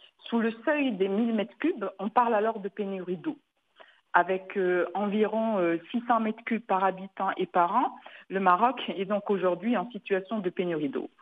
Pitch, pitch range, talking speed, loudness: 205 Hz, 185-230 Hz, 175 wpm, -28 LUFS